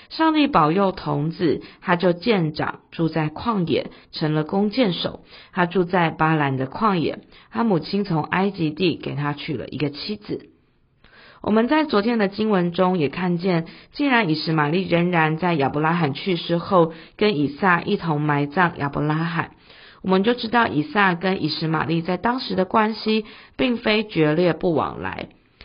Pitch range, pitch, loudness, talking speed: 155-200 Hz, 175 Hz, -21 LUFS, 250 characters per minute